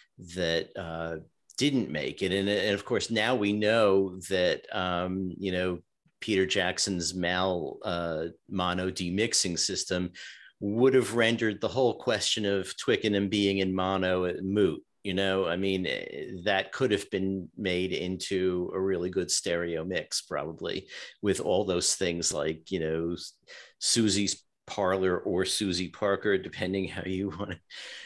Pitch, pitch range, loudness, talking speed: 95 Hz, 90-100 Hz, -29 LUFS, 145 wpm